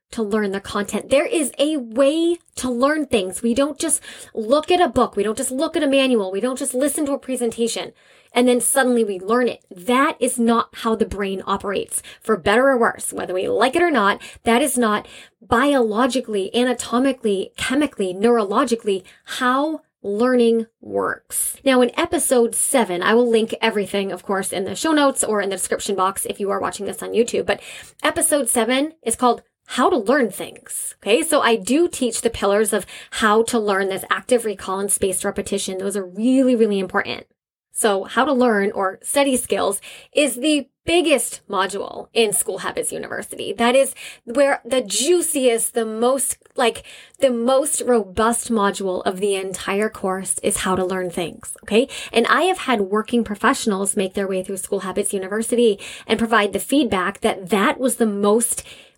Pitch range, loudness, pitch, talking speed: 200-265 Hz, -20 LUFS, 230 Hz, 185 wpm